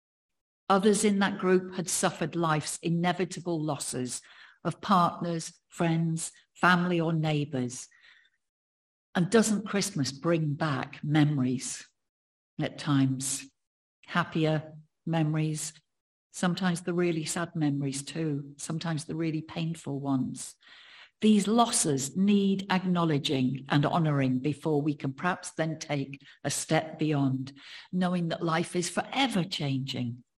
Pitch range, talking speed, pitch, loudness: 140-180 Hz, 115 wpm, 160 Hz, -29 LUFS